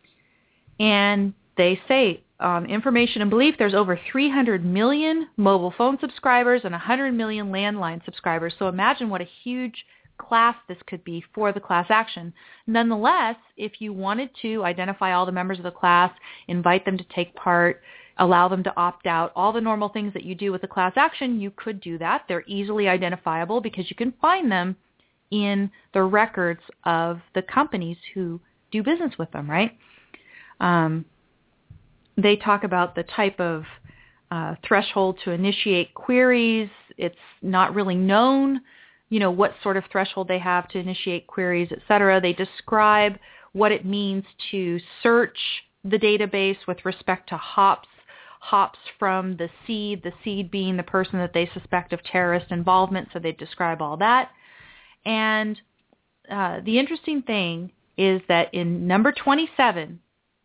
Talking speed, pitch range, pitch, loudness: 160 wpm, 180-220 Hz, 195 Hz, -22 LUFS